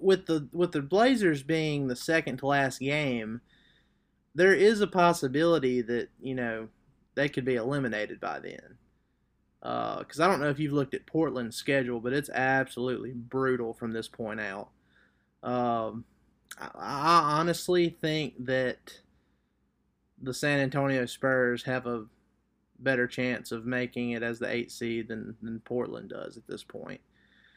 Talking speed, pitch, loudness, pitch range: 155 wpm, 130 Hz, -29 LUFS, 120-150 Hz